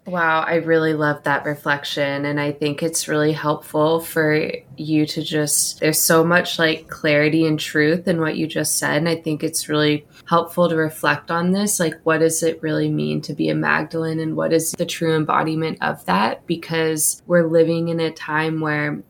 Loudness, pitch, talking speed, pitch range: -19 LUFS, 160 Hz, 200 wpm, 150-165 Hz